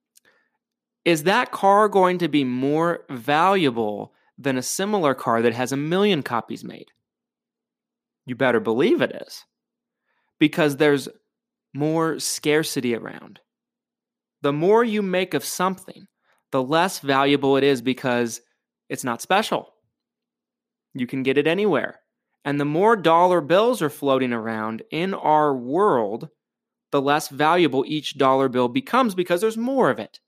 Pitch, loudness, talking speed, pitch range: 165 Hz, -21 LUFS, 140 wpm, 140-225 Hz